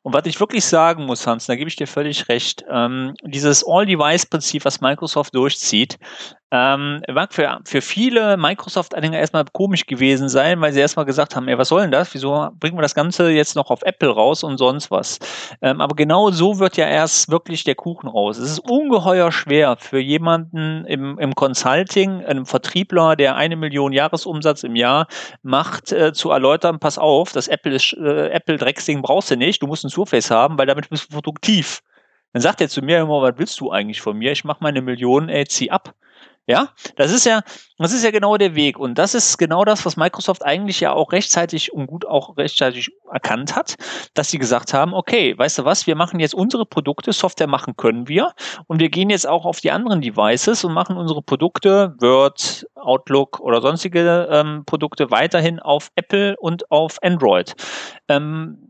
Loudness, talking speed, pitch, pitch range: -17 LUFS, 195 wpm, 155 Hz, 140-175 Hz